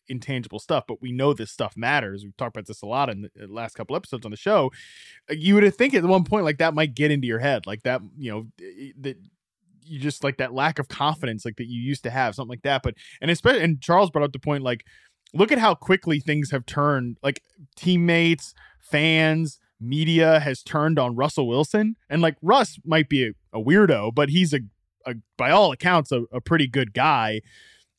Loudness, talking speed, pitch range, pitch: -22 LUFS, 220 wpm, 125-160 Hz, 145 Hz